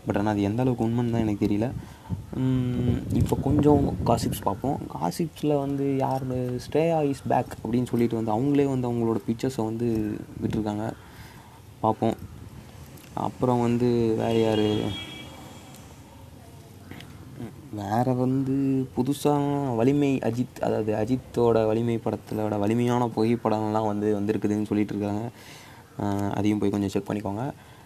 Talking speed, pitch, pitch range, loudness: 115 wpm, 115 Hz, 105-130 Hz, -26 LUFS